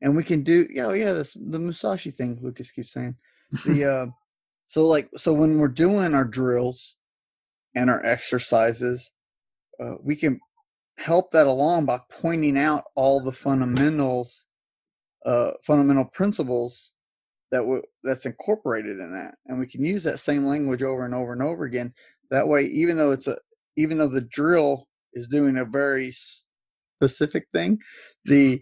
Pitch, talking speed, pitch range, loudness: 140 Hz, 165 wpm, 125-155 Hz, -23 LUFS